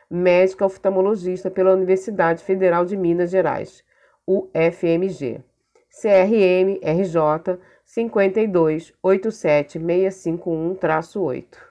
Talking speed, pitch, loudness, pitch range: 60 wpm, 185 Hz, -20 LUFS, 170-195 Hz